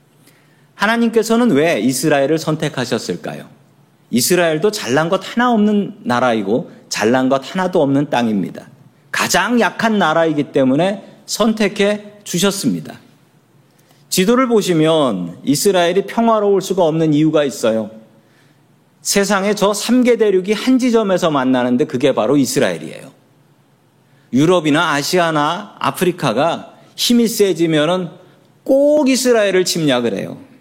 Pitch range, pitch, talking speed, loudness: 150-210 Hz, 180 Hz, 290 characters per minute, -15 LUFS